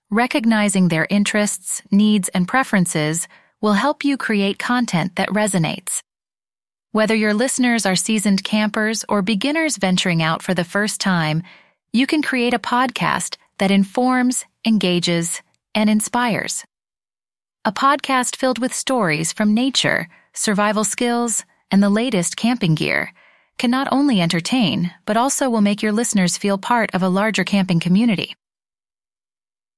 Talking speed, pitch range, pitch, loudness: 135 wpm, 190-245 Hz, 215 Hz, -18 LUFS